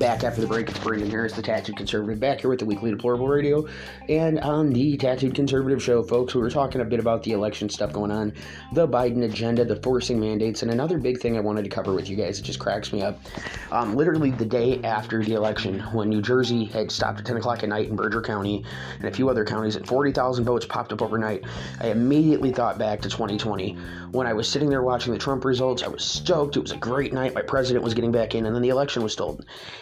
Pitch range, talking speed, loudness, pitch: 105-130 Hz, 245 wpm, -24 LUFS, 115 Hz